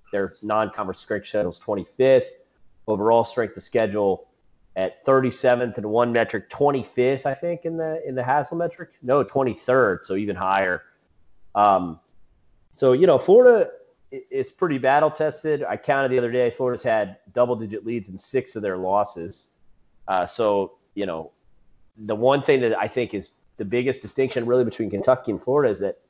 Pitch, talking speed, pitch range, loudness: 125 Hz, 170 wpm, 110-160 Hz, -22 LUFS